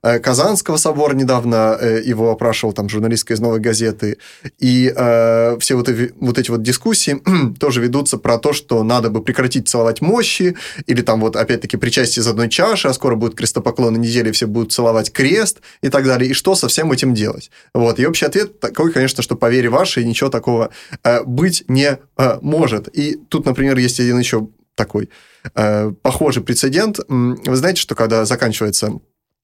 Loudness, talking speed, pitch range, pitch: -15 LUFS, 180 wpm, 115-135 Hz, 125 Hz